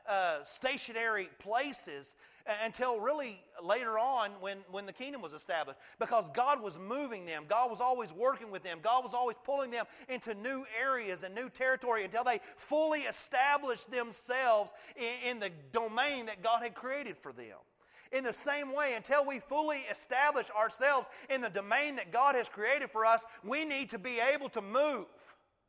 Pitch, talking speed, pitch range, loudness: 245 Hz, 175 wpm, 220-270 Hz, -34 LUFS